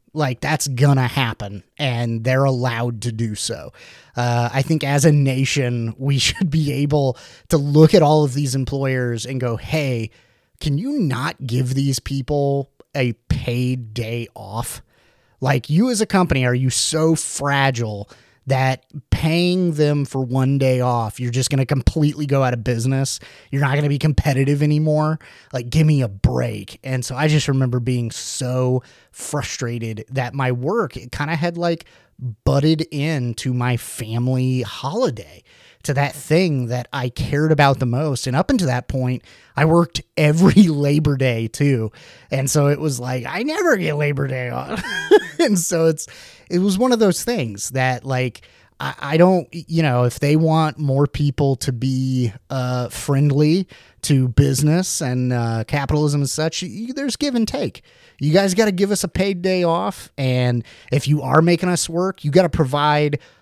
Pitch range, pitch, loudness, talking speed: 125-155 Hz, 140 Hz, -19 LUFS, 175 wpm